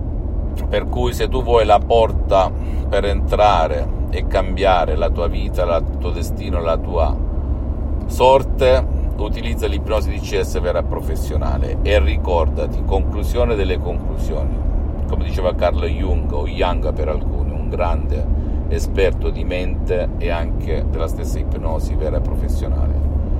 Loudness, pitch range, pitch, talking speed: -19 LUFS, 70-80 Hz, 75 Hz, 130 wpm